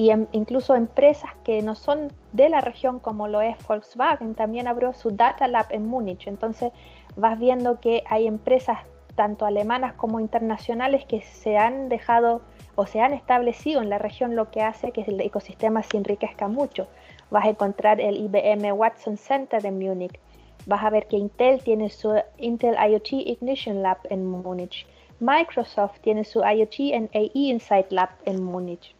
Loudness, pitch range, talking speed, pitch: -23 LUFS, 210-245 Hz, 170 wpm, 220 Hz